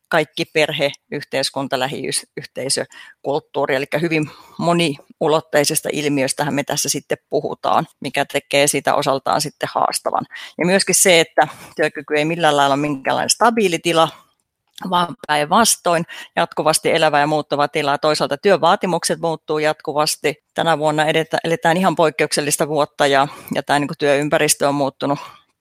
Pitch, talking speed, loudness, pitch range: 155 Hz, 125 wpm, -18 LUFS, 145-165 Hz